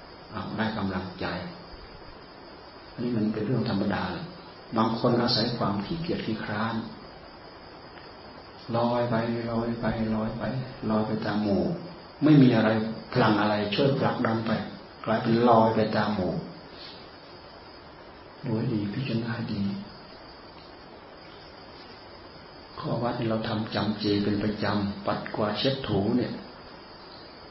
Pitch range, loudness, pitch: 105-115 Hz, -27 LUFS, 110 Hz